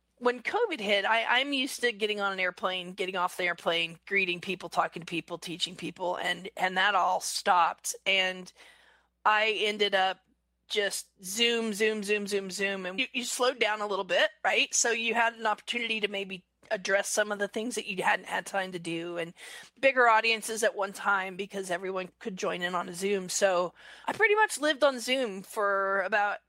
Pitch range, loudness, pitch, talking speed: 185-230 Hz, -28 LUFS, 200 Hz, 200 wpm